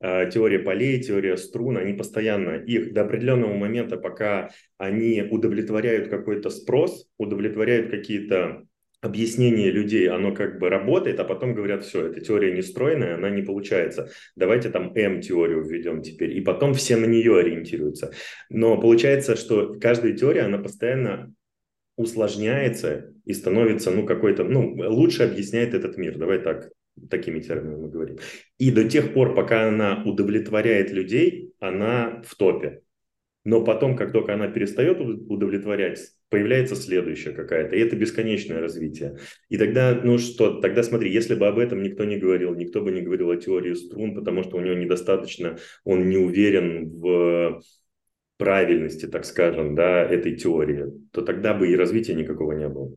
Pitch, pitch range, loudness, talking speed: 105 Hz, 90-115 Hz, -23 LUFS, 155 wpm